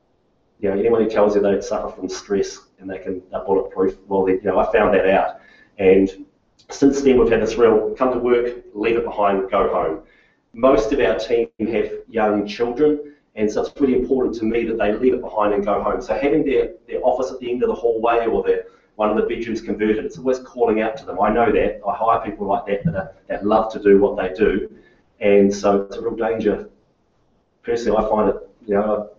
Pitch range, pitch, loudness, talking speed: 100-140 Hz, 110 Hz, -19 LUFS, 235 wpm